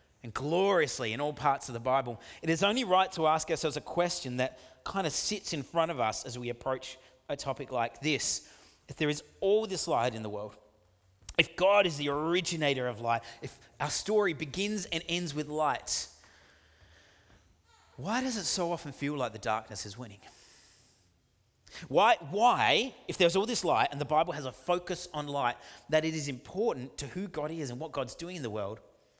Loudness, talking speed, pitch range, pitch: -31 LUFS, 200 wpm, 115-170 Hz, 145 Hz